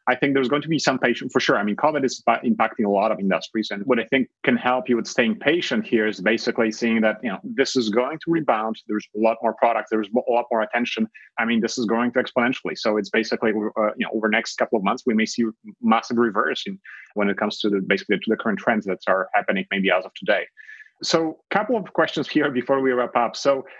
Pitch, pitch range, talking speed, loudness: 120 Hz, 110-135 Hz, 260 wpm, -22 LUFS